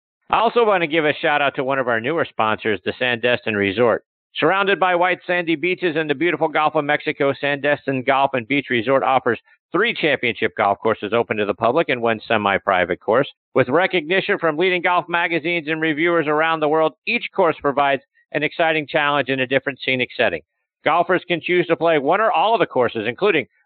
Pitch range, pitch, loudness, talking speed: 130-170 Hz, 150 Hz, -19 LUFS, 205 wpm